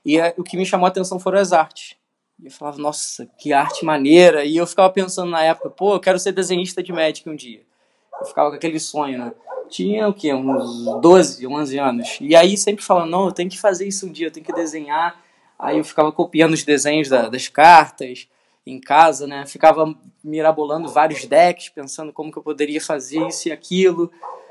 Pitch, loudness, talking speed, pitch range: 160 Hz, -17 LUFS, 210 wpm, 150-180 Hz